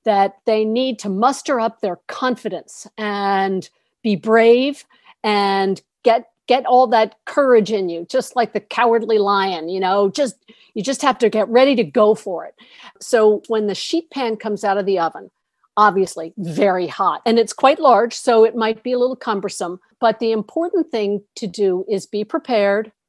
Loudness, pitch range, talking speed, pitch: -18 LUFS, 200-240 Hz, 180 wpm, 220 Hz